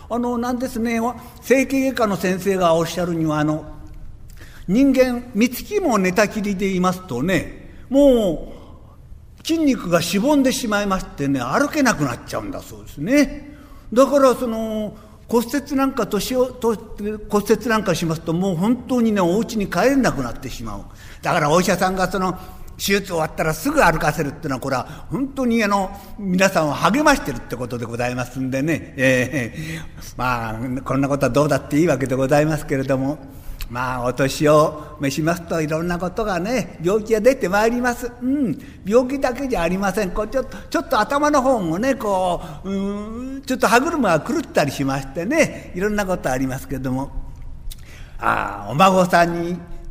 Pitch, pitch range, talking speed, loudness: 190 Hz, 150-240 Hz, 355 characters per minute, -20 LUFS